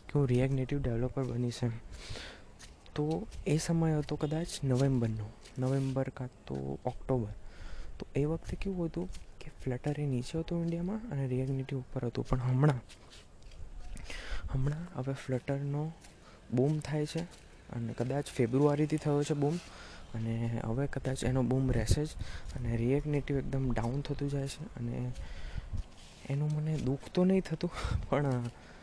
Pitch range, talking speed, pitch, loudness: 120-150 Hz, 135 wpm, 130 Hz, -34 LUFS